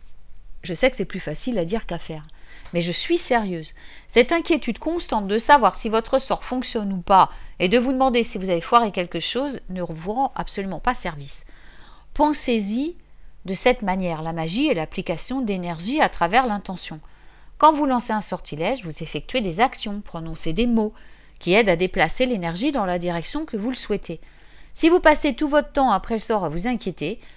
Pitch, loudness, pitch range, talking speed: 210 Hz, -22 LUFS, 175-255 Hz, 195 wpm